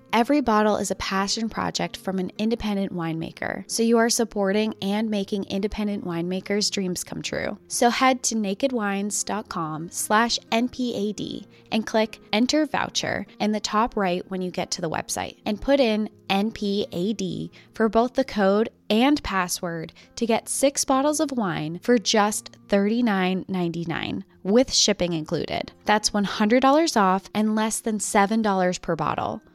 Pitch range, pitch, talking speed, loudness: 190-230 Hz, 210 Hz, 140 wpm, -24 LUFS